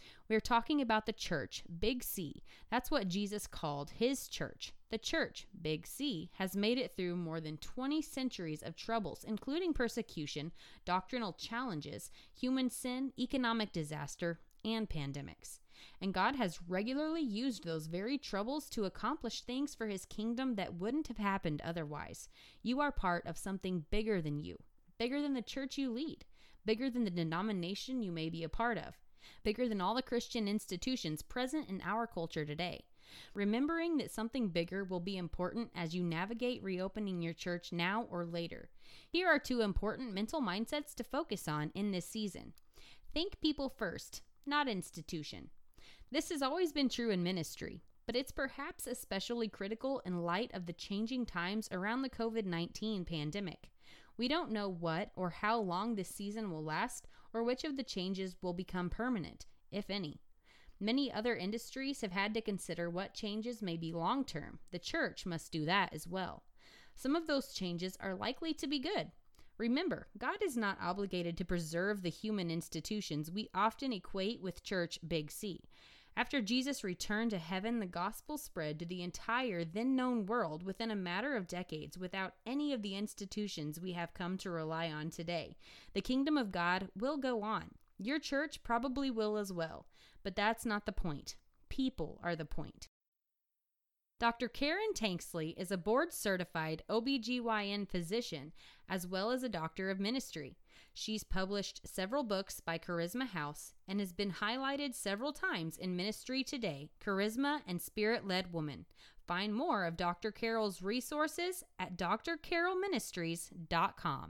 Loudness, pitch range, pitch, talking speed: -39 LUFS, 175-250 Hz, 210 Hz, 165 wpm